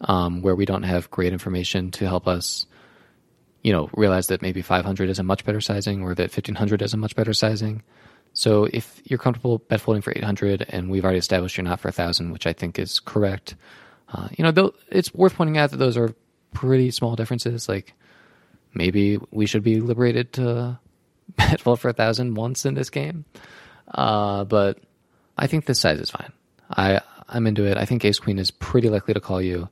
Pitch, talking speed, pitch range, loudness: 105 Hz, 200 wpm, 95-120 Hz, -22 LUFS